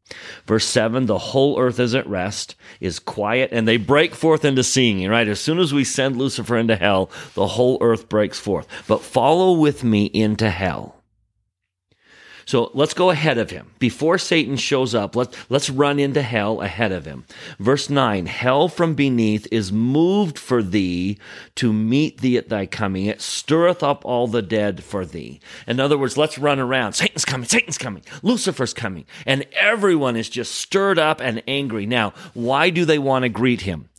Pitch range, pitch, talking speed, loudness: 110-140 Hz, 125 Hz, 185 wpm, -19 LUFS